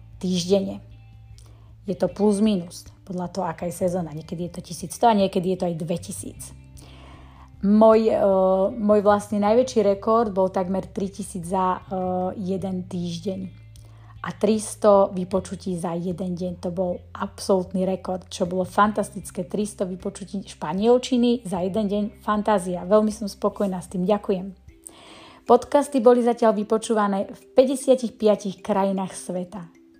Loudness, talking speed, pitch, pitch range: -23 LUFS, 135 wpm, 190 Hz, 180-210 Hz